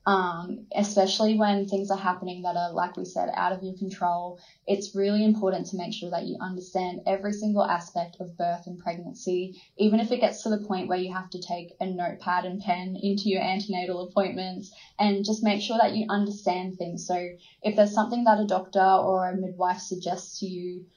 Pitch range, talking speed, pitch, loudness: 180-205 Hz, 205 wpm, 185 Hz, -27 LUFS